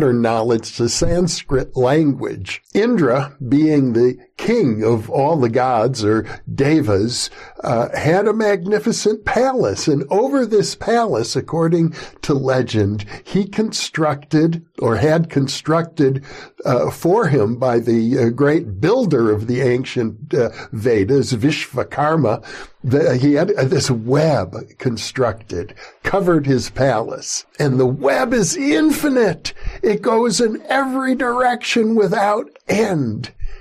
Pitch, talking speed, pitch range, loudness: 145 Hz, 120 wpm, 125-195 Hz, -17 LUFS